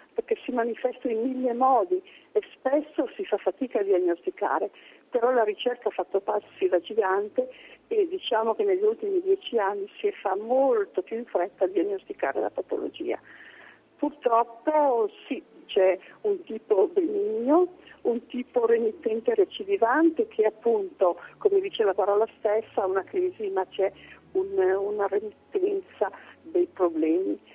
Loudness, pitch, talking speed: -26 LUFS, 295 Hz, 145 wpm